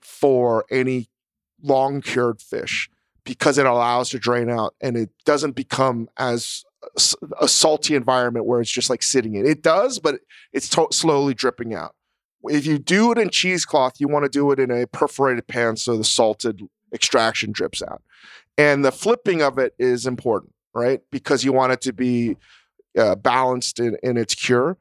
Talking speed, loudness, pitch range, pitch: 175 wpm, -20 LUFS, 120-140 Hz, 130 Hz